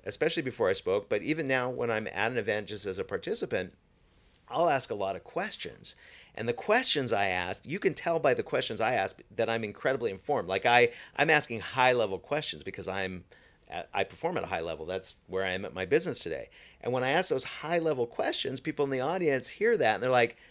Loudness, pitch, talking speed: -30 LUFS, 135 Hz, 230 wpm